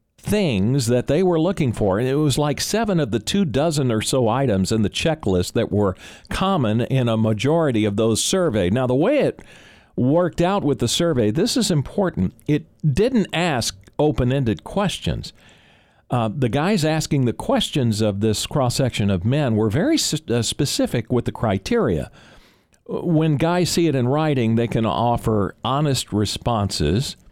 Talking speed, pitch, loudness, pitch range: 170 wpm, 130 Hz, -20 LUFS, 110-155 Hz